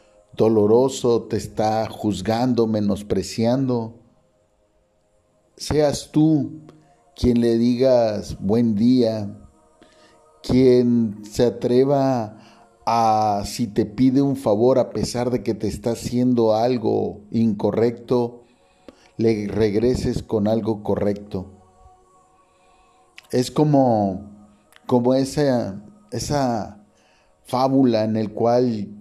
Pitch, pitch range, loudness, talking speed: 115 Hz, 105-125 Hz, -20 LUFS, 90 wpm